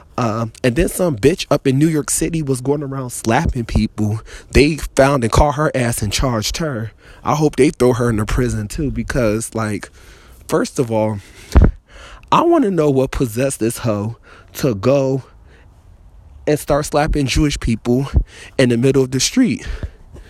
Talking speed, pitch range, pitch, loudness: 175 wpm, 105-145 Hz, 125 Hz, -17 LUFS